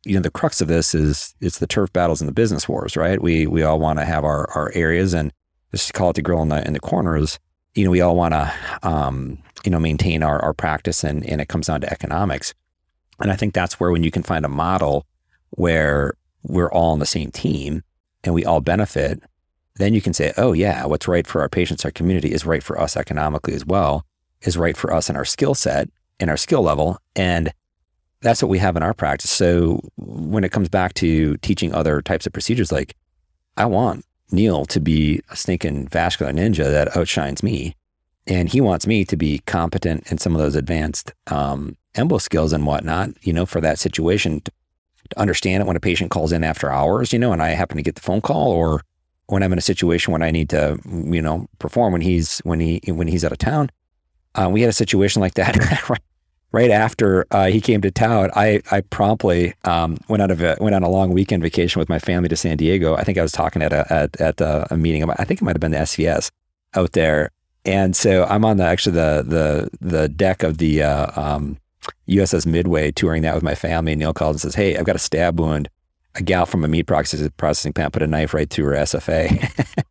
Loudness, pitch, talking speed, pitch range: -19 LUFS, 80 Hz, 230 wpm, 75-95 Hz